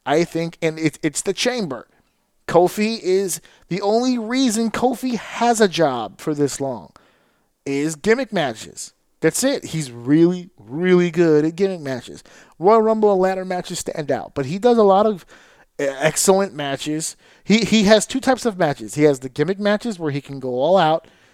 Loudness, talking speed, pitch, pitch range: -19 LUFS, 180 wpm, 175 Hz, 155-215 Hz